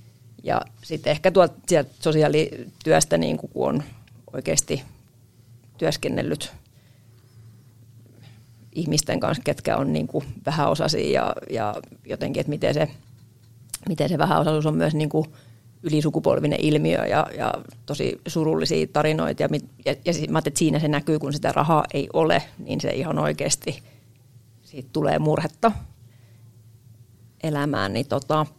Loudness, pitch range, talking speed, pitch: -23 LUFS, 115-155 Hz, 115 wpm, 130 Hz